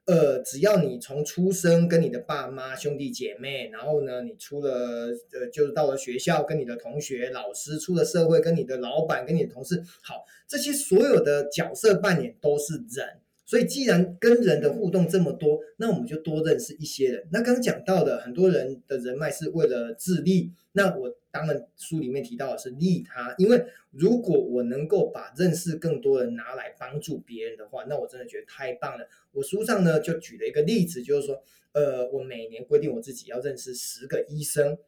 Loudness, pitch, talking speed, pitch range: -26 LUFS, 155 Hz, 300 characters per minute, 135-195 Hz